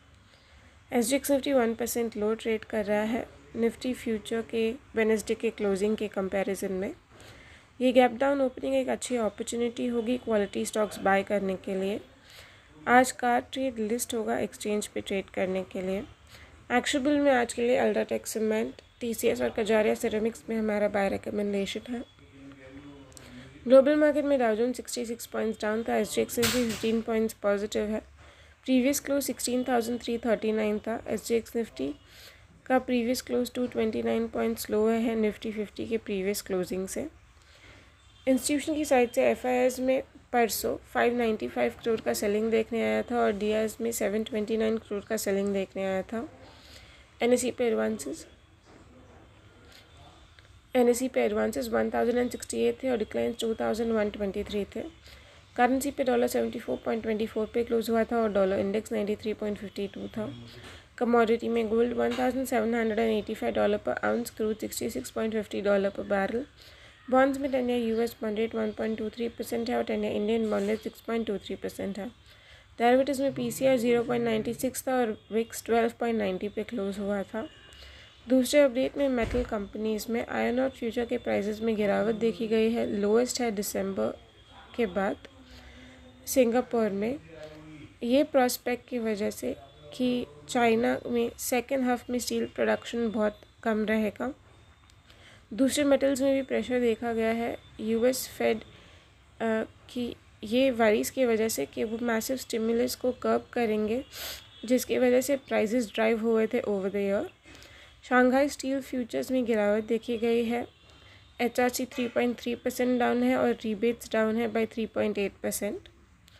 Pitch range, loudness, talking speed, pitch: 200-245 Hz, -28 LUFS, 175 wpm, 225 Hz